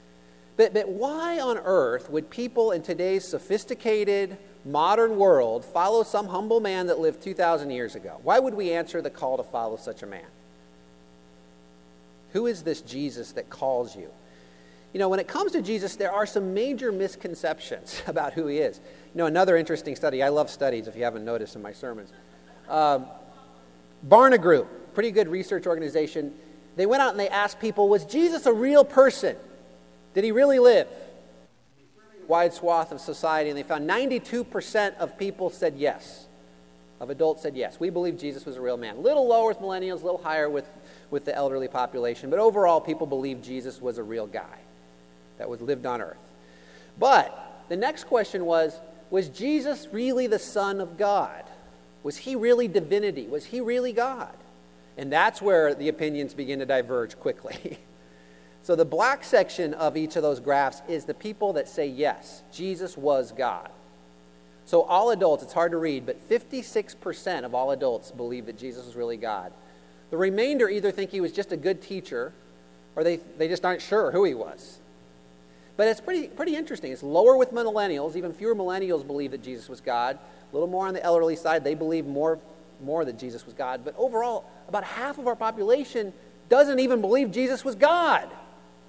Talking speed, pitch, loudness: 185 wpm, 165 Hz, -25 LUFS